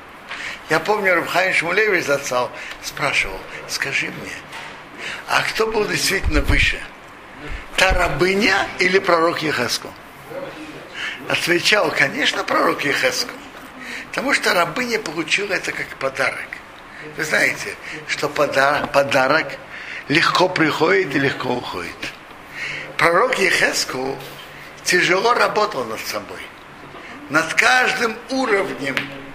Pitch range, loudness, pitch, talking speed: 170-220 Hz, -18 LUFS, 185 Hz, 95 wpm